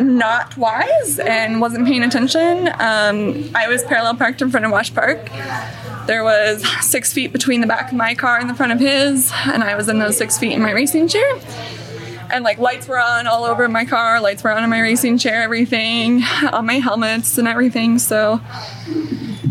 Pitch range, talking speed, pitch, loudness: 225-260 Hz, 200 wpm, 235 Hz, -16 LUFS